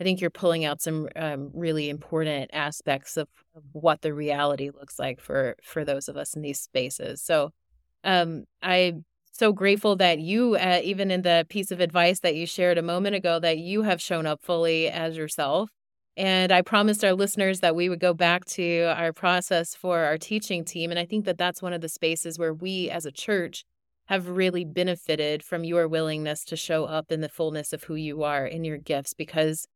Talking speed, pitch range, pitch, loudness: 210 wpm, 155-180 Hz, 170 Hz, -26 LUFS